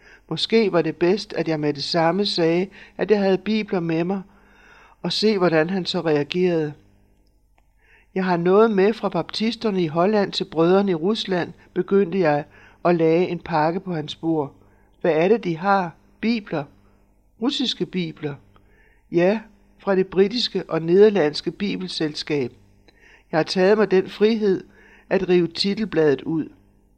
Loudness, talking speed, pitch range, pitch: -21 LUFS, 150 wpm, 155-200 Hz, 180 Hz